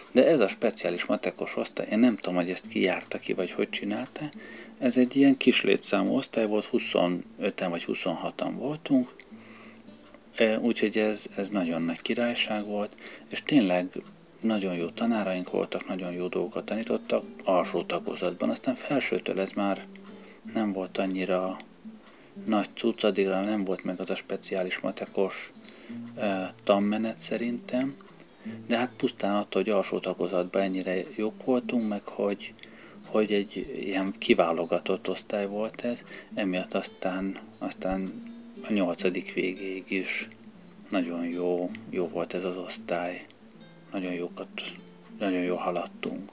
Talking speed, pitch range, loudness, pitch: 135 wpm, 95-115 Hz, -29 LUFS, 100 Hz